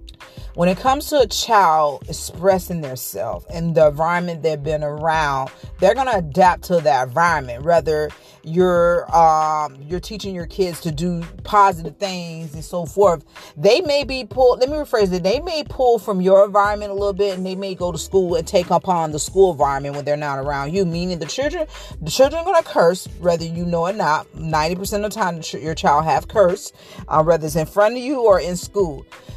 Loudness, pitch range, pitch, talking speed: -19 LUFS, 160-200 Hz, 175 Hz, 210 wpm